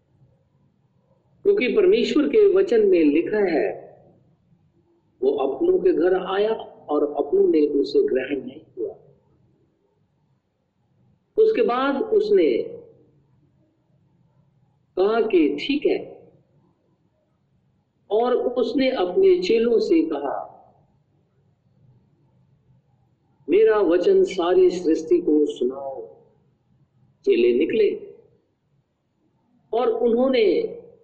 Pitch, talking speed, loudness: 345 Hz, 80 wpm, -20 LUFS